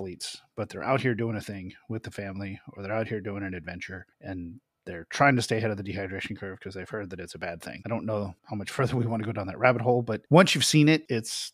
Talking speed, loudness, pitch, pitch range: 285 wpm, -27 LUFS, 110 Hz, 100-125 Hz